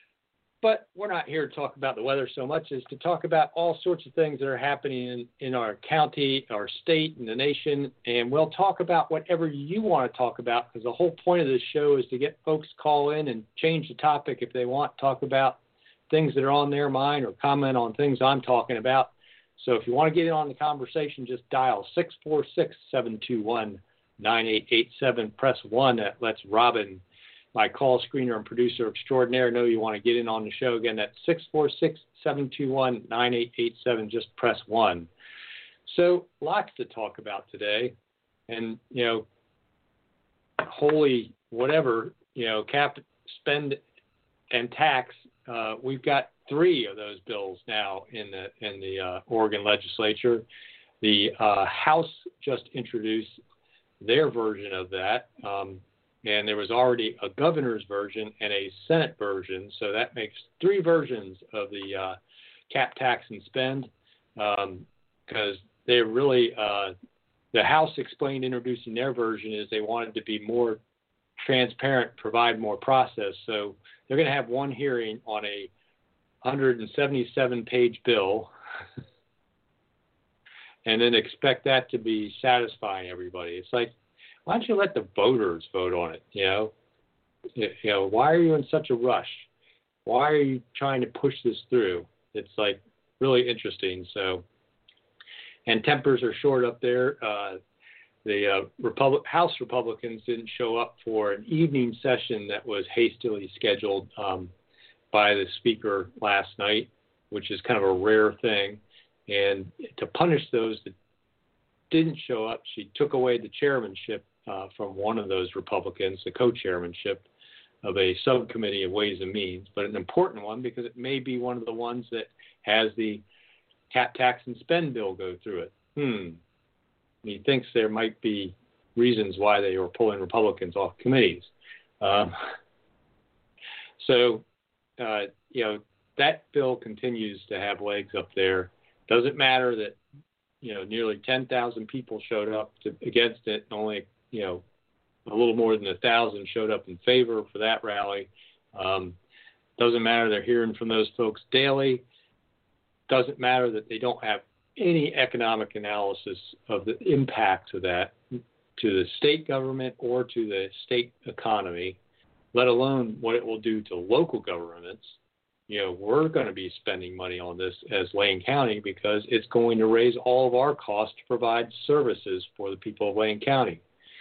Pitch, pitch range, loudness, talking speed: 120 Hz, 105-135 Hz, -26 LUFS, 170 wpm